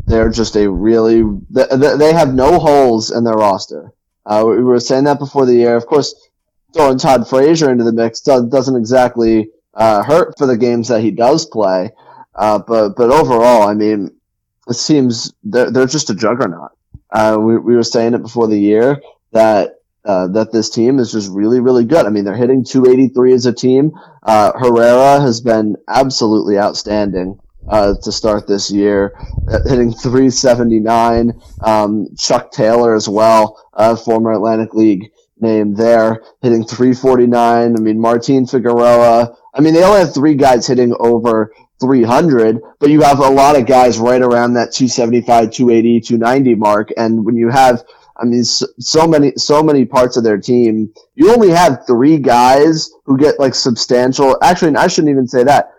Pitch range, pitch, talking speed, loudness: 110-130 Hz, 120 Hz, 175 wpm, -11 LUFS